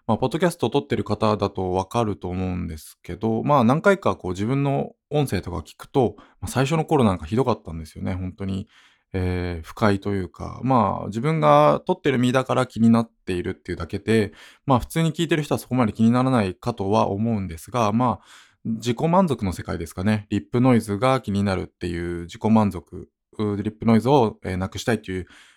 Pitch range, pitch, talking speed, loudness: 95-125 Hz, 110 Hz, 425 characters per minute, -23 LUFS